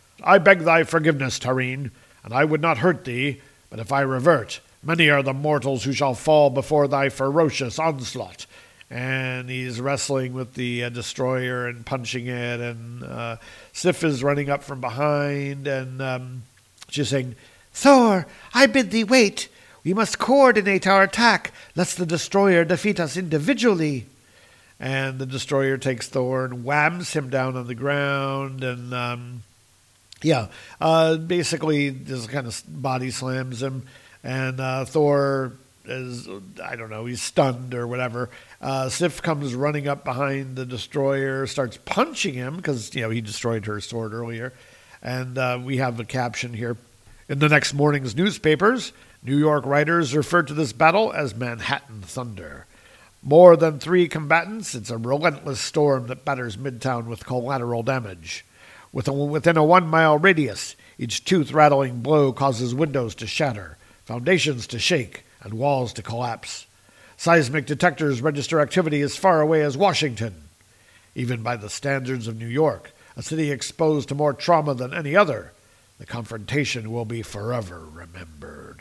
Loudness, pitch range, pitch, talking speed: -22 LUFS, 125-155 Hz, 135 Hz, 155 wpm